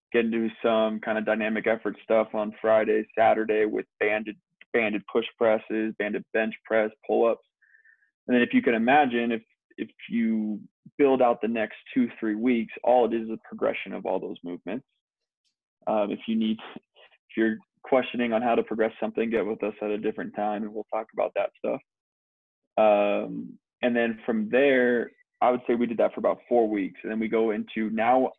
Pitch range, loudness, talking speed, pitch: 110-120 Hz, -26 LUFS, 195 wpm, 110 Hz